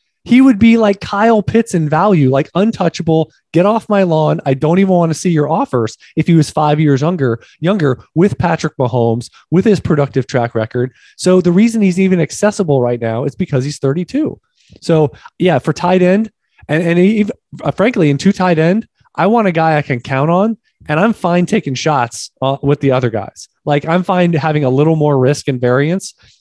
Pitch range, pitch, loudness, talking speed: 140-190 Hz, 160 Hz, -13 LUFS, 205 wpm